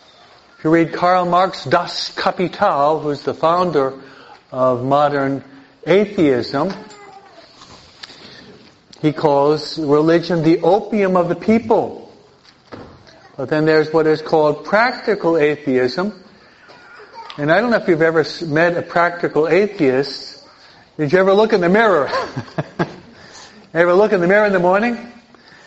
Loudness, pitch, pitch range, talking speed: -16 LUFS, 170 Hz, 150-195 Hz, 130 wpm